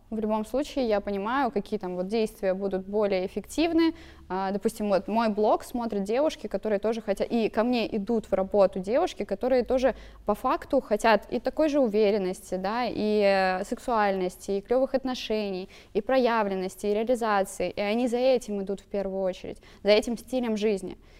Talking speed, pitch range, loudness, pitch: 165 wpm, 195-240 Hz, -27 LUFS, 215 Hz